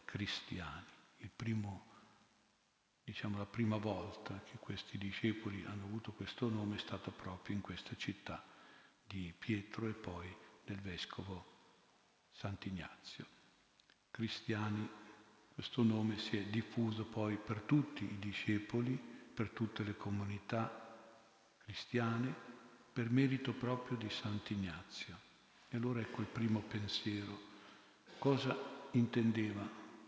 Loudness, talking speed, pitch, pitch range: -42 LUFS, 110 wpm, 110 Hz, 100-115 Hz